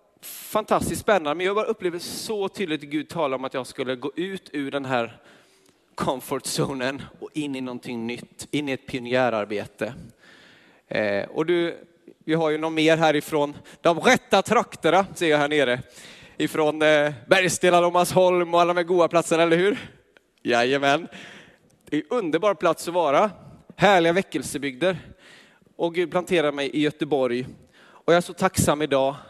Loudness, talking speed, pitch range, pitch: -23 LUFS, 160 wpm, 140-180 Hz, 160 Hz